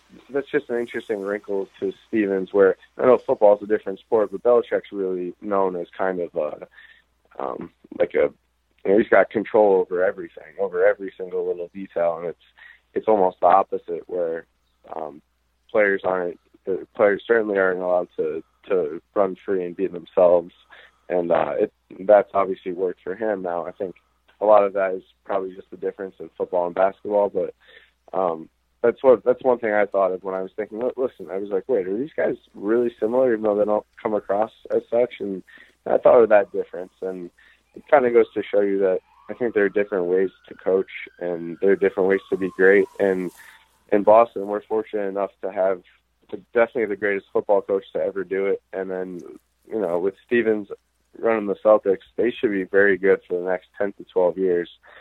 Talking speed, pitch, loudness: 200 wpm, 110 Hz, -22 LUFS